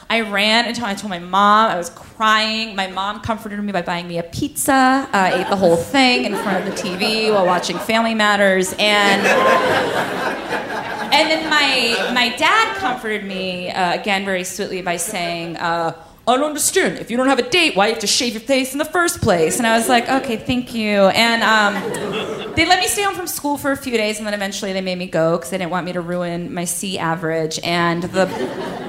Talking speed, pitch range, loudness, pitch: 225 wpm, 180-245 Hz, -17 LUFS, 210 Hz